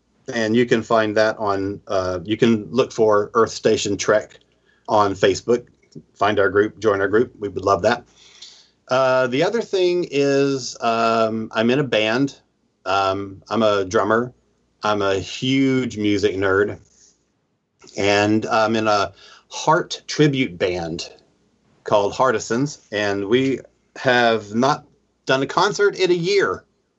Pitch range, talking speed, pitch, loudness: 105-130 Hz, 140 wpm, 115 Hz, -20 LUFS